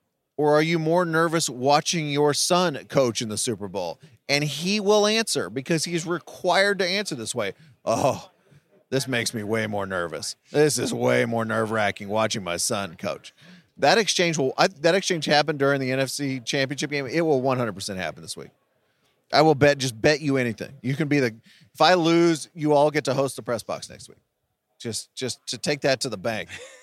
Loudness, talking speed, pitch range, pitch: -23 LUFS, 200 wpm, 120-165 Hz, 145 Hz